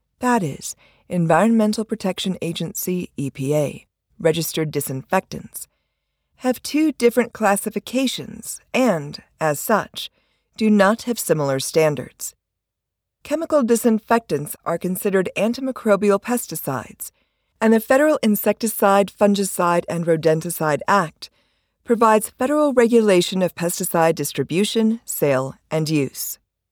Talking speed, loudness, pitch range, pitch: 95 wpm, -20 LUFS, 160-225 Hz, 190 Hz